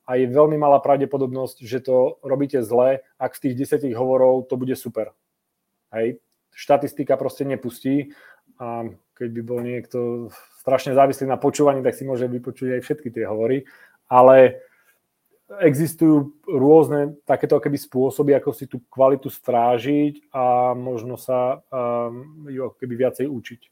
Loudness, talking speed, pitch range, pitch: -20 LUFS, 140 wpm, 125-140 Hz, 130 Hz